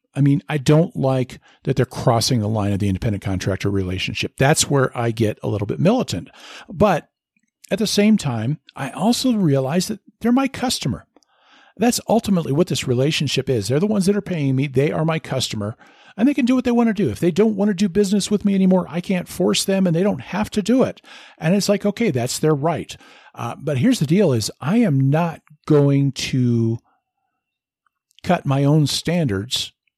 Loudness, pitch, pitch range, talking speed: -19 LUFS, 160 Hz, 130-205 Hz, 210 wpm